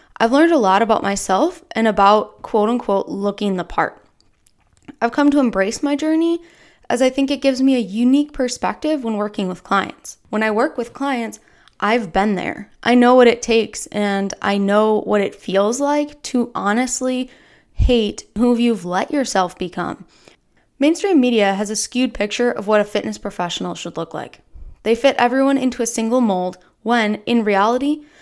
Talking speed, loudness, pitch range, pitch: 180 wpm, -18 LUFS, 205-265 Hz, 235 Hz